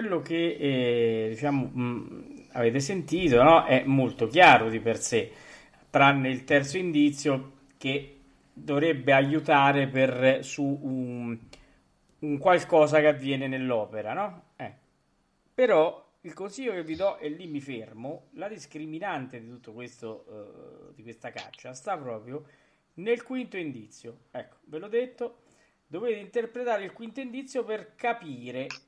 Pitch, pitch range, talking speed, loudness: 145 Hz, 130-185 Hz, 135 wpm, -26 LUFS